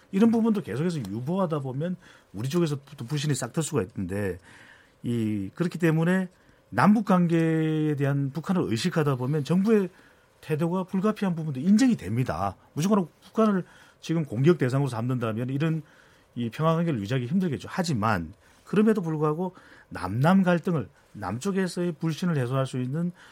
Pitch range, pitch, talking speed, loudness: 130-180 Hz, 155 Hz, 355 characters per minute, -26 LUFS